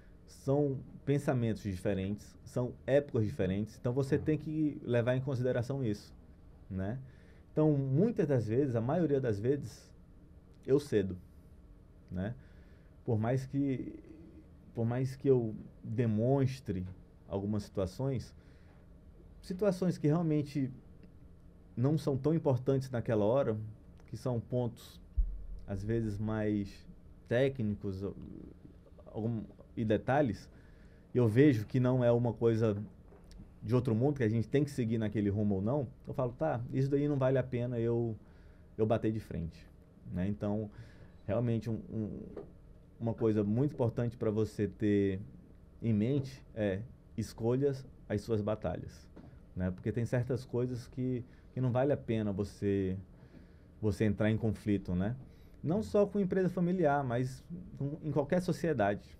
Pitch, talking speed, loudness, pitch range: 115 Hz, 140 wpm, -34 LUFS, 95-130 Hz